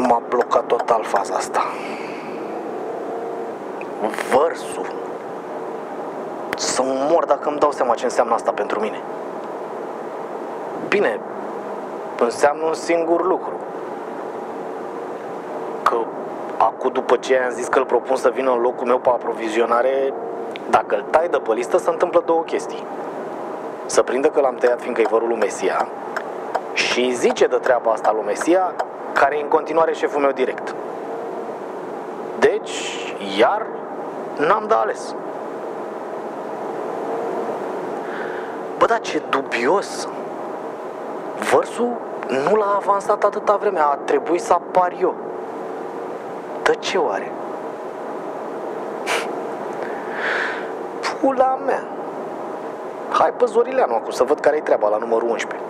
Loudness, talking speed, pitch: -21 LUFS, 115 wpm, 165 Hz